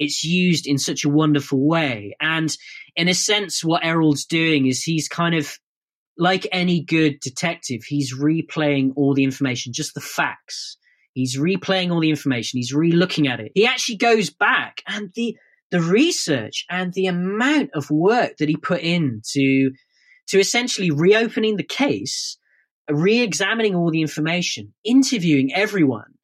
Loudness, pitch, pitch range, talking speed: -20 LUFS, 160 Hz, 145-185 Hz, 160 wpm